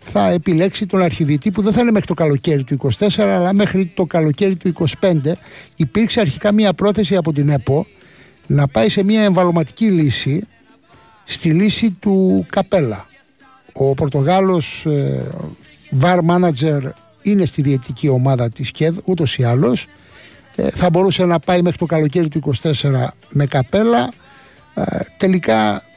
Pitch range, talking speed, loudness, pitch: 140-190 Hz, 150 wpm, -16 LUFS, 170 Hz